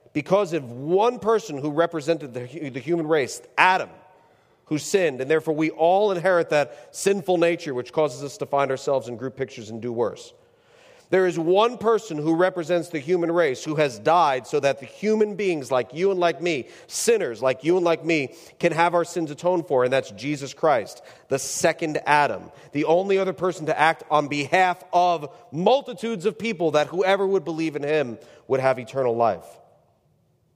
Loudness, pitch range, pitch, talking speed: -23 LUFS, 145-185 Hz, 165 Hz, 190 wpm